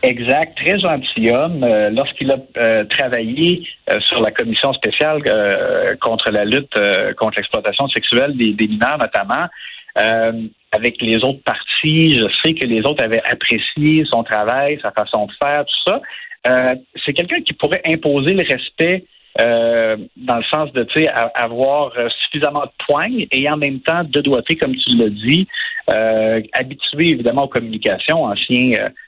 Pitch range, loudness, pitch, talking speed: 120-160 Hz, -16 LUFS, 140 Hz, 165 wpm